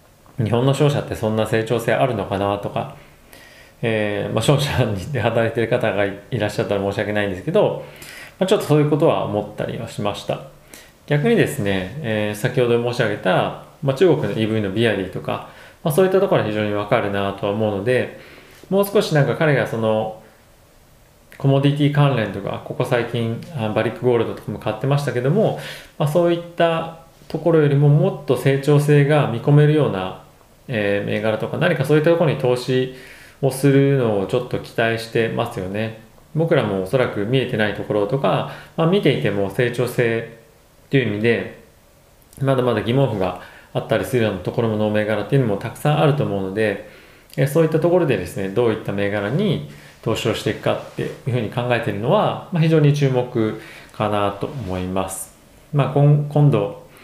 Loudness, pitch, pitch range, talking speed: -20 LUFS, 120 Hz, 105-140 Hz, 385 characters per minute